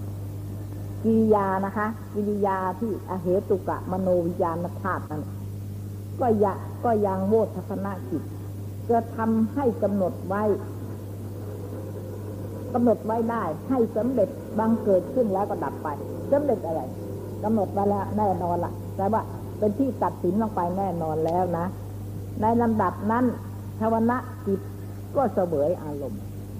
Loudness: -26 LUFS